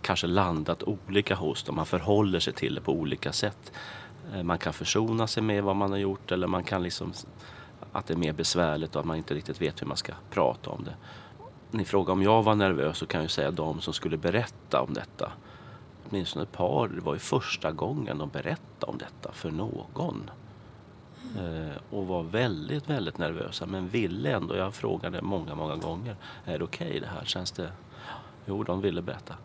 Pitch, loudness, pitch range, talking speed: 95 Hz, -30 LUFS, 85-110 Hz, 200 wpm